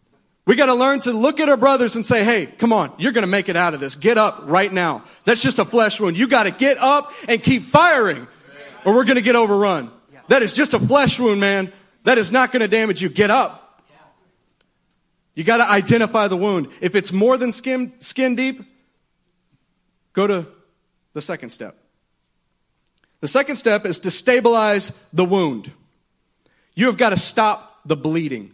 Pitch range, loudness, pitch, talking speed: 190-250 Hz, -17 LUFS, 215 Hz, 185 wpm